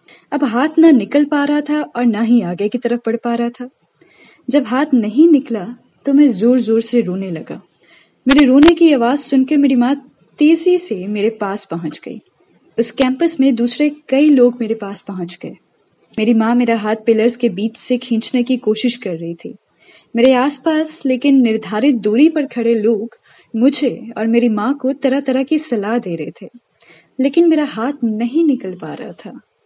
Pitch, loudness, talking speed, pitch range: 245 Hz, -15 LUFS, 190 wpm, 225-280 Hz